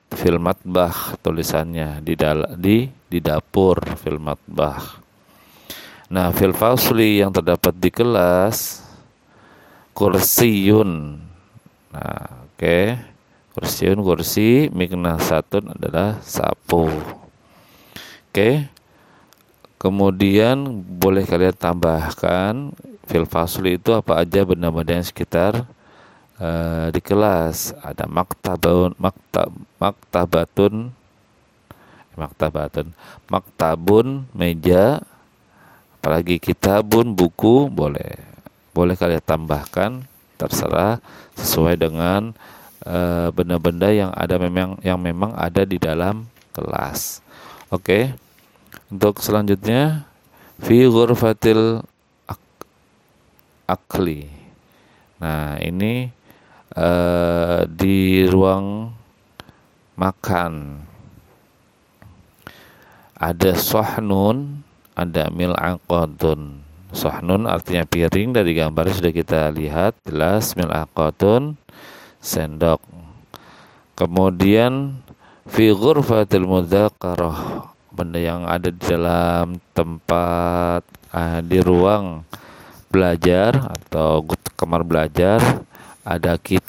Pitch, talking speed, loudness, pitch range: 90 Hz, 80 wpm, -19 LUFS, 85-105 Hz